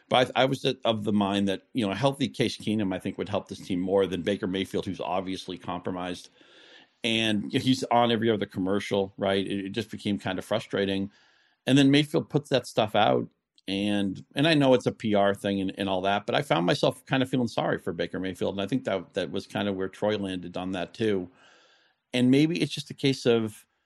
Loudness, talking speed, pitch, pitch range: -27 LUFS, 225 wpm, 105 Hz, 95-125 Hz